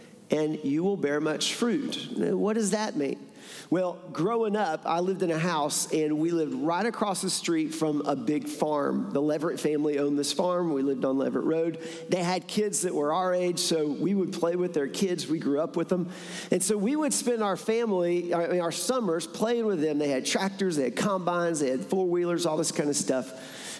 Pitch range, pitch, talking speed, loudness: 155-195 Hz, 175 Hz, 215 wpm, -27 LUFS